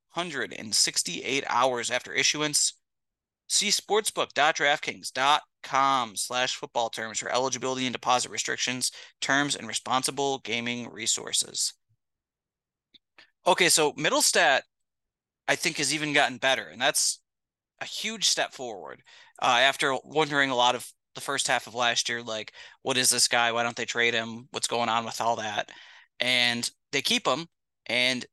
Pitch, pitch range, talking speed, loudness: 125 Hz, 120-140 Hz, 145 wpm, -25 LUFS